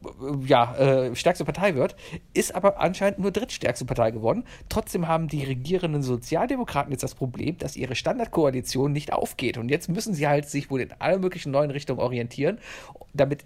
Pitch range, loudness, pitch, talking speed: 130-175 Hz, -25 LUFS, 145 Hz, 175 wpm